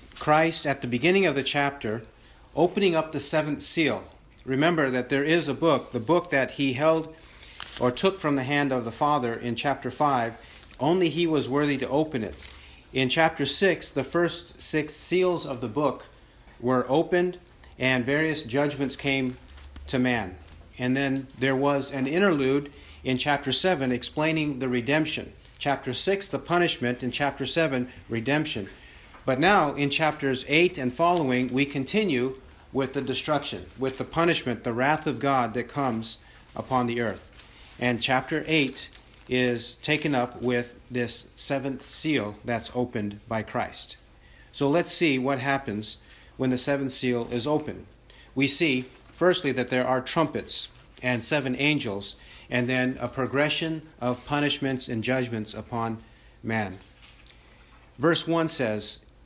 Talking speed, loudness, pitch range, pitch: 155 wpm, -25 LUFS, 120-150 Hz, 135 Hz